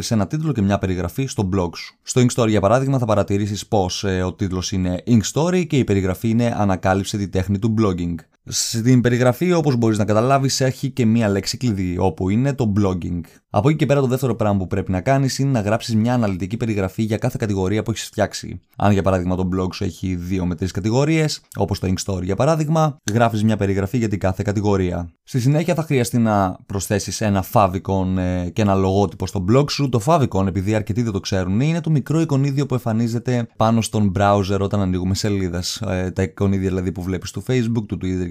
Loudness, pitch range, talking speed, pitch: -20 LUFS, 95-125 Hz, 210 wpm, 105 Hz